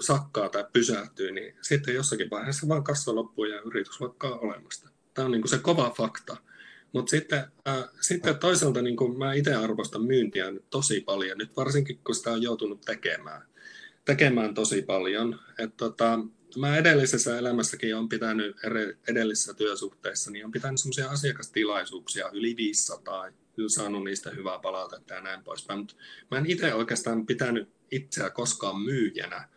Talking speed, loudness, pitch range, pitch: 155 wpm, -28 LUFS, 110-145 Hz, 125 Hz